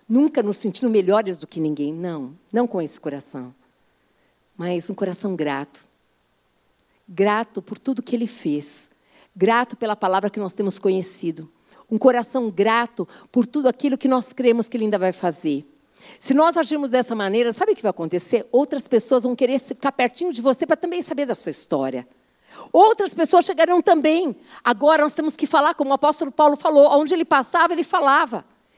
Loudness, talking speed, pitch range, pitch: -20 LUFS, 180 wpm, 190-290 Hz, 240 Hz